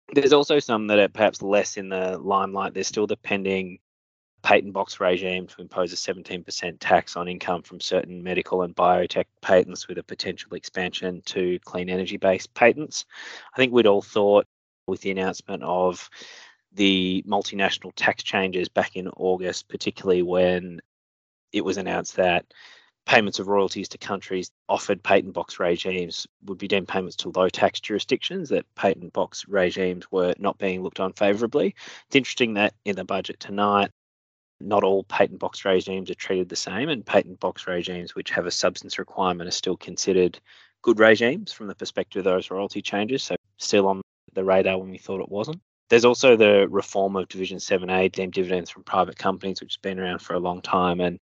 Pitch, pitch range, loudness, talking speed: 95 Hz, 90-100 Hz, -24 LUFS, 185 wpm